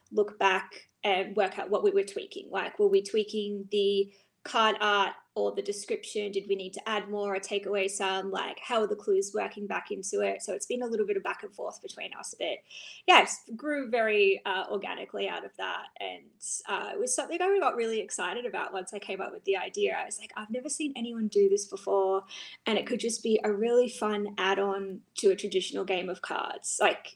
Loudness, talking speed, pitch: -30 LUFS, 230 wpm, 215 Hz